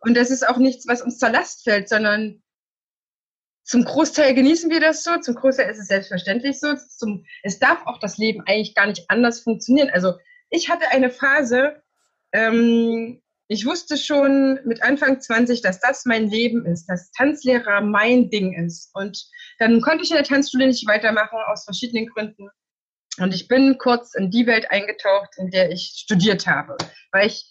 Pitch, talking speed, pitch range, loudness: 235 Hz, 180 wpm, 210-270 Hz, -19 LUFS